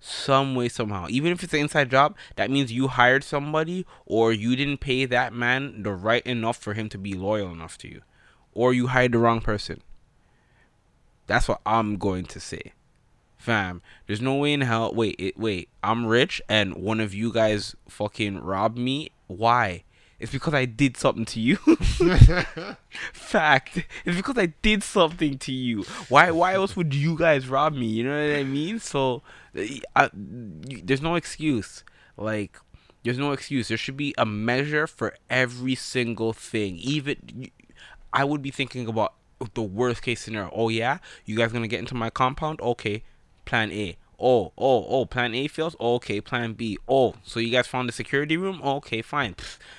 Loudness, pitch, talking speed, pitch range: -24 LUFS, 120 Hz, 180 wpm, 110-140 Hz